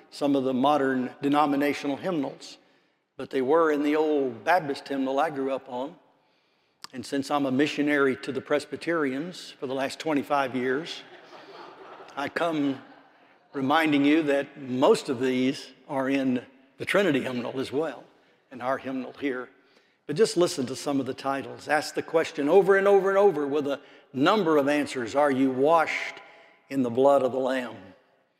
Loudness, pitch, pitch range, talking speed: -26 LUFS, 140 Hz, 135-150 Hz, 170 wpm